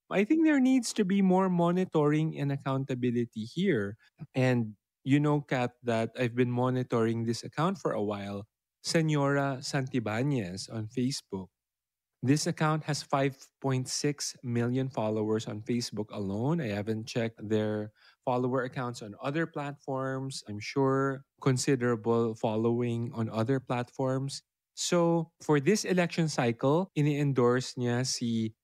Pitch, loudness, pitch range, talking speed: 130 Hz, -30 LUFS, 115-150 Hz, 130 wpm